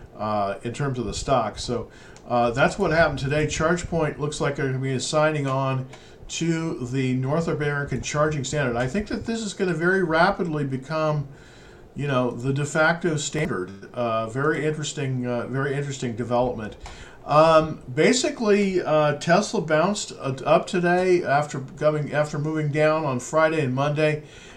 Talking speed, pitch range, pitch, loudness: 160 wpm, 130-160 Hz, 150 Hz, -23 LUFS